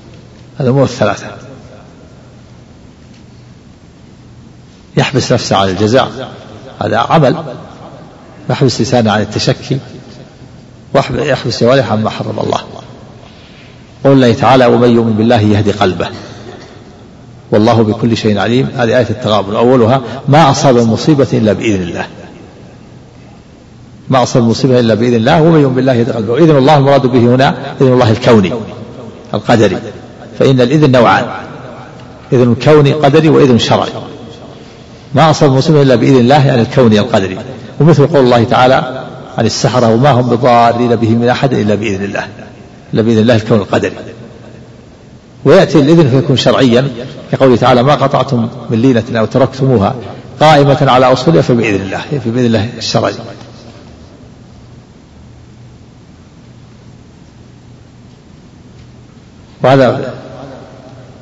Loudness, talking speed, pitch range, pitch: -10 LUFS, 115 wpm, 115-135 Hz, 125 Hz